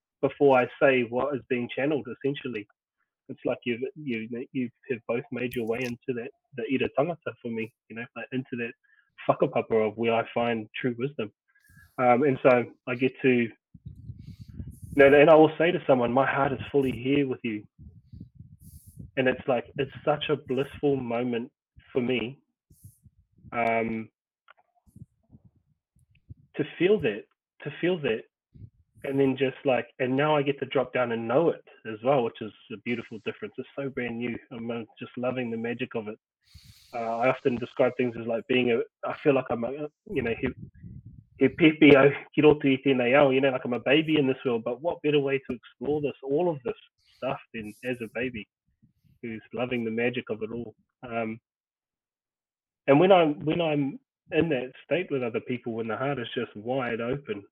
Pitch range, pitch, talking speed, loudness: 115-140 Hz, 125 Hz, 180 wpm, -26 LUFS